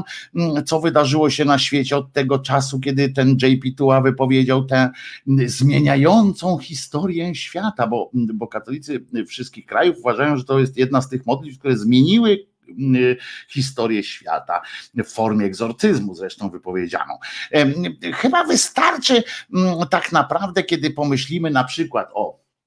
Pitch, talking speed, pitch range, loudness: 140 Hz, 125 wpm, 130-165 Hz, -19 LUFS